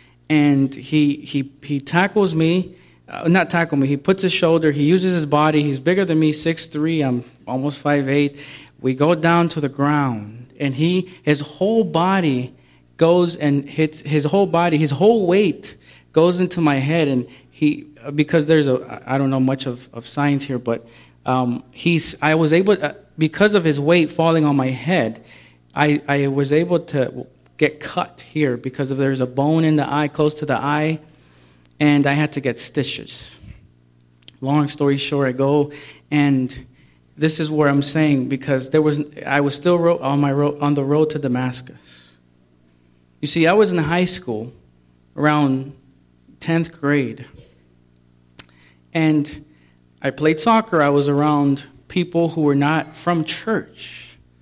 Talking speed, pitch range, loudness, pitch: 170 wpm, 130-160 Hz, -19 LUFS, 145 Hz